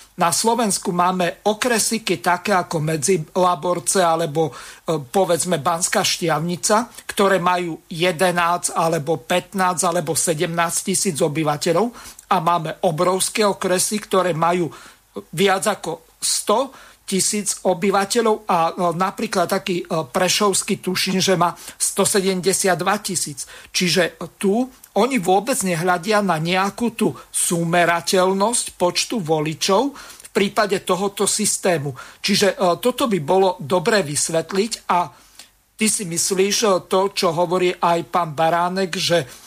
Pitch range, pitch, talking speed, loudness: 170-200 Hz, 185 Hz, 110 wpm, -19 LUFS